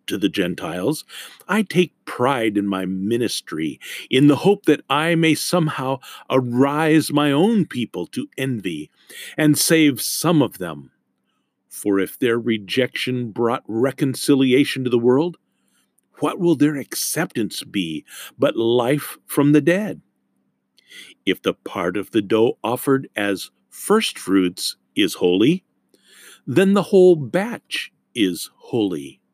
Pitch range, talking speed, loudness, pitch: 115-160 Hz, 130 wpm, -20 LUFS, 135 Hz